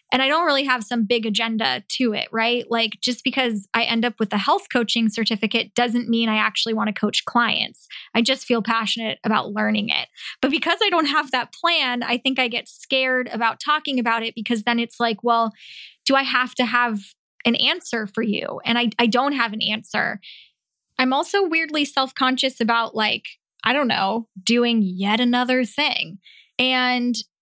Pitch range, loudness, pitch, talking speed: 225-255 Hz, -21 LUFS, 235 Hz, 195 wpm